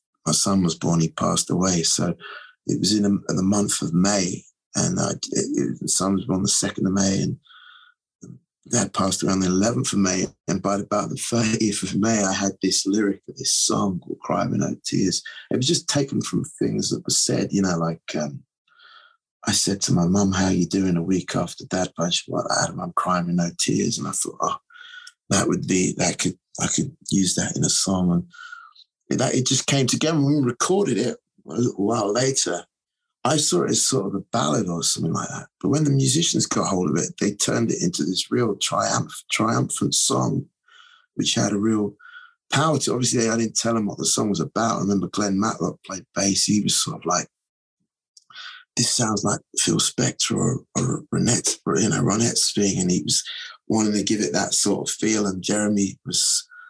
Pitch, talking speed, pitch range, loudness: 105 Hz, 210 wpm, 95-140 Hz, -22 LUFS